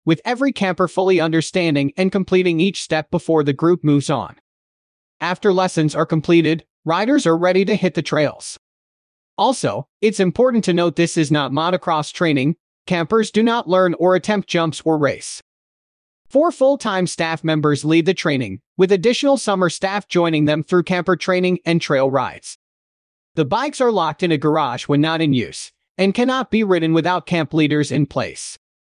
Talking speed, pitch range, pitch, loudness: 175 wpm, 155-190 Hz, 175 Hz, -18 LUFS